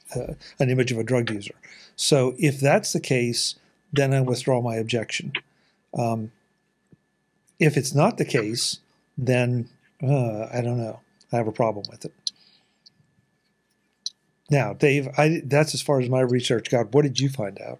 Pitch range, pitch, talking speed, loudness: 120-155 Hz, 135 Hz, 160 wpm, -23 LUFS